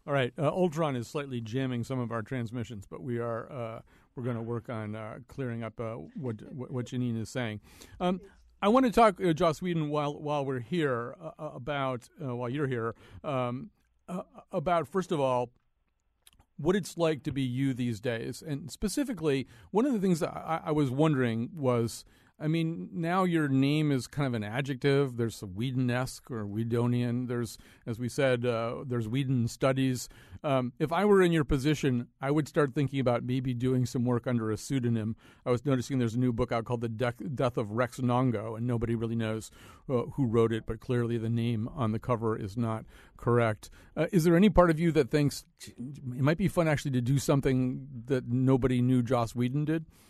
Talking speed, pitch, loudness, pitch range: 205 wpm, 125 Hz, -30 LUFS, 120-150 Hz